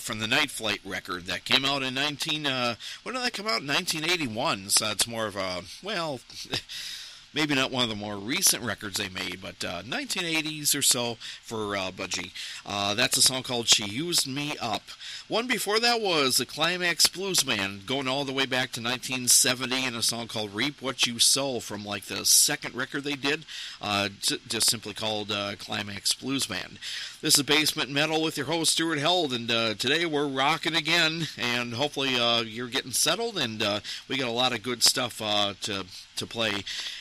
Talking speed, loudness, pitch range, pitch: 200 wpm, -25 LUFS, 105-150 Hz, 125 Hz